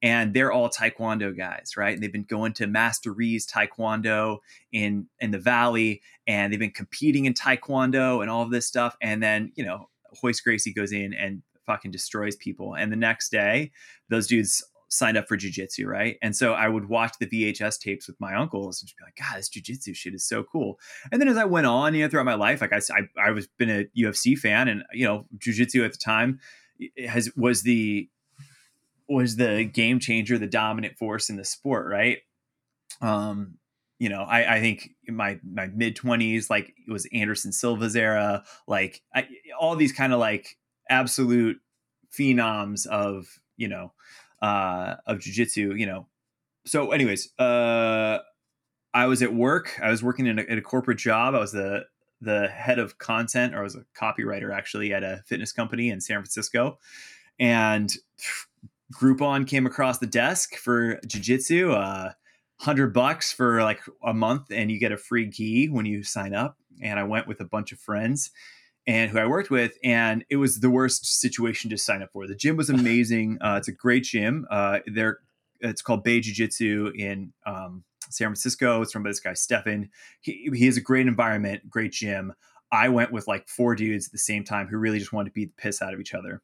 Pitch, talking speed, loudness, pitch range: 115 Hz, 200 wpm, -25 LUFS, 105-125 Hz